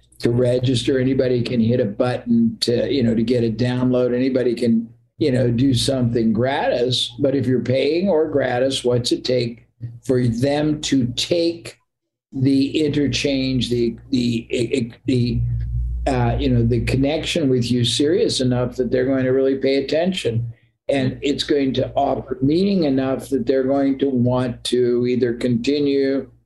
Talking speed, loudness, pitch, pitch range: 165 wpm, -19 LUFS, 125 Hz, 120-135 Hz